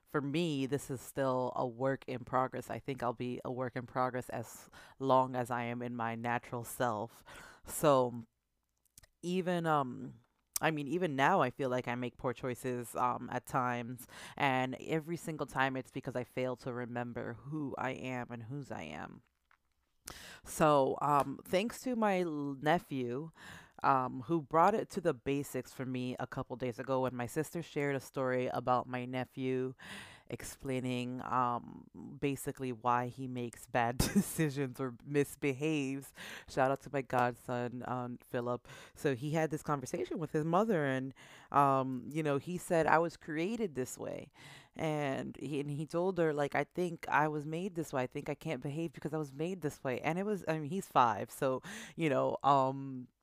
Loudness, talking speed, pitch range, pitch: -35 LUFS, 180 wpm, 125-150 Hz, 135 Hz